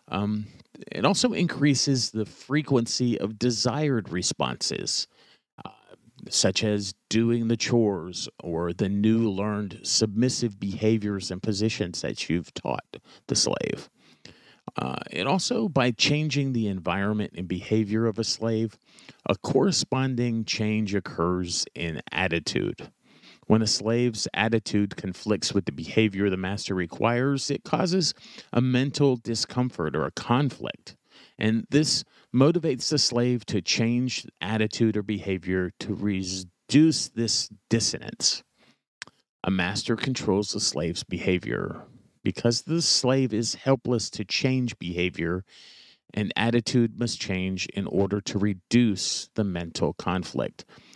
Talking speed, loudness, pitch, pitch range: 120 wpm, -26 LUFS, 110 Hz, 100-125 Hz